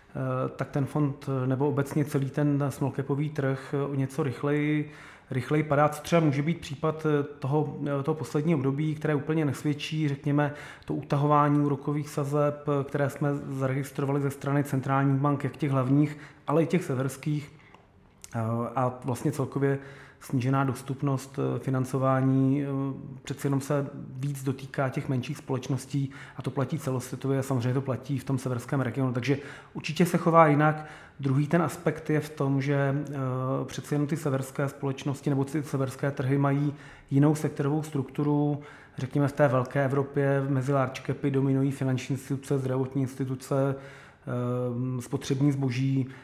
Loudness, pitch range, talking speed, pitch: -28 LUFS, 135-145 Hz, 145 wpm, 140 Hz